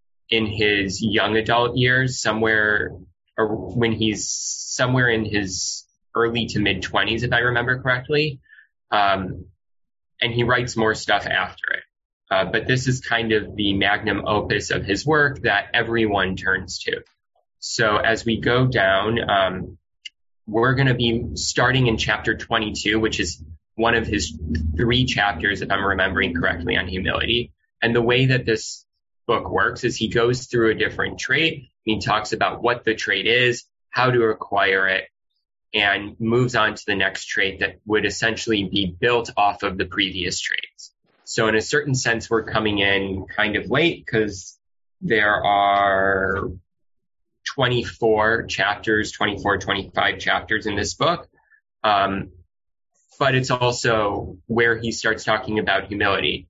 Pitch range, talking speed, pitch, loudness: 95-115 Hz, 155 wpm, 110 Hz, -21 LUFS